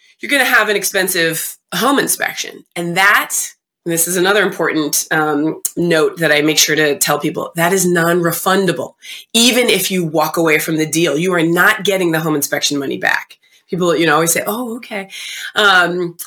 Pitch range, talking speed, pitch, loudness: 155-195 Hz, 195 wpm, 170 Hz, -14 LUFS